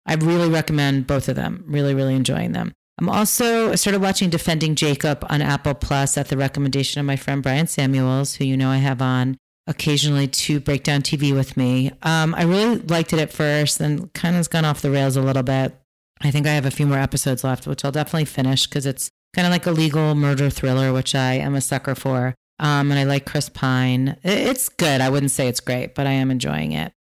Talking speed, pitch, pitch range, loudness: 235 wpm, 140 Hz, 135-155 Hz, -20 LUFS